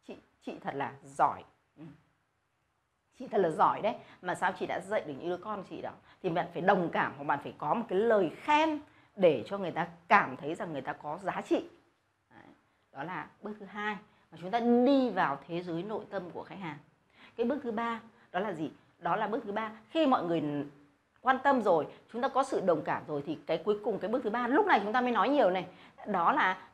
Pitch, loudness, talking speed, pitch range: 210 Hz, -31 LUFS, 235 wpm, 170-255 Hz